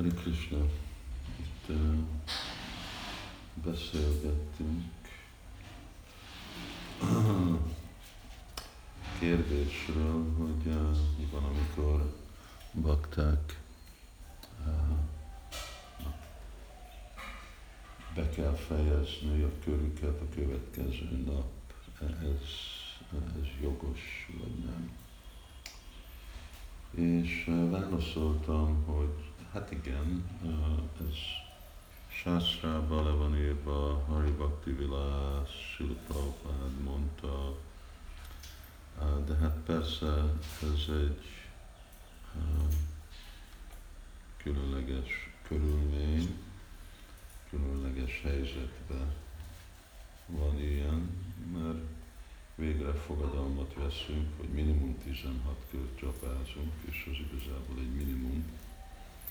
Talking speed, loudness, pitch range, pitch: 60 wpm, -36 LUFS, 70-85 Hz, 75 Hz